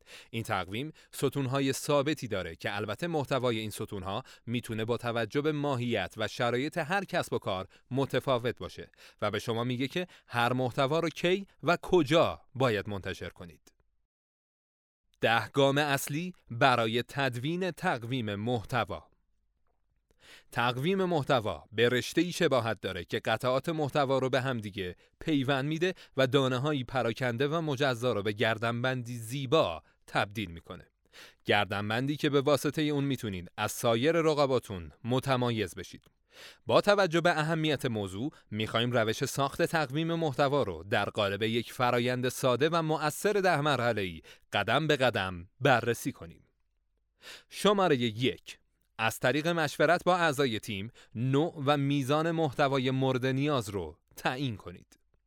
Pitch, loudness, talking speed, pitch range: 130 Hz, -30 LUFS, 135 wpm, 115-150 Hz